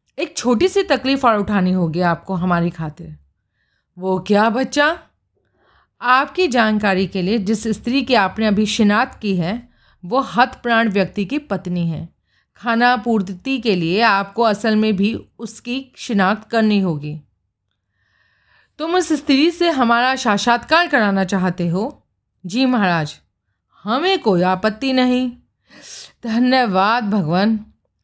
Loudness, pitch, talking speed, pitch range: -17 LUFS, 215 Hz, 135 wpm, 185-250 Hz